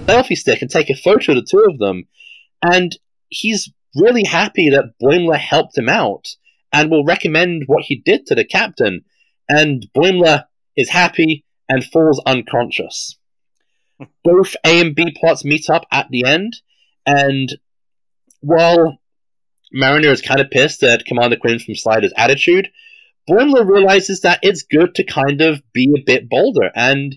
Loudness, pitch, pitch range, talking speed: -13 LUFS, 160 Hz, 140-180 Hz, 160 wpm